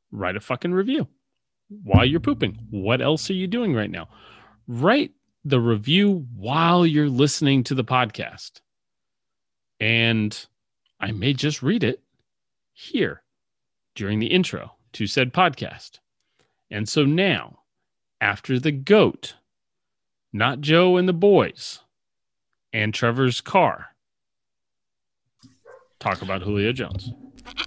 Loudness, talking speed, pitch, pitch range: -21 LUFS, 115 wpm, 130 Hz, 110-175 Hz